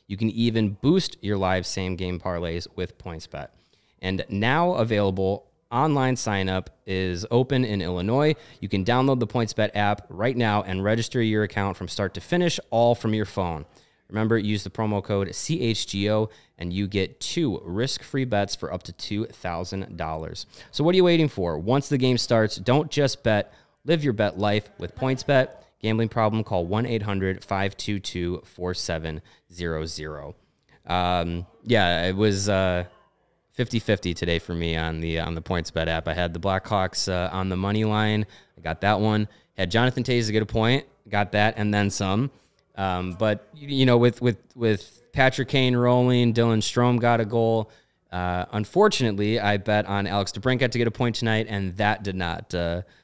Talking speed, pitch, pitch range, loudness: 175 wpm, 105 Hz, 95-120 Hz, -24 LUFS